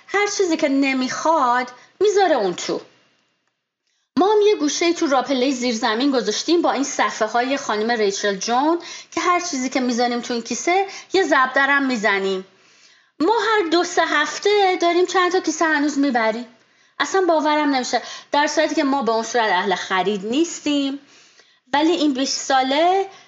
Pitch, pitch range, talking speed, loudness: 280 Hz, 245-345 Hz, 160 wpm, -19 LUFS